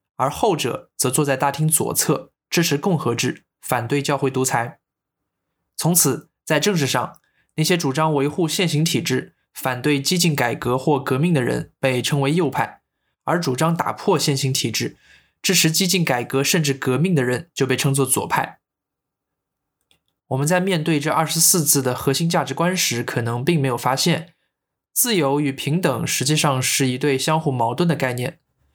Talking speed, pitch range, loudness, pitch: 255 characters per minute, 130-165 Hz, -20 LUFS, 145 Hz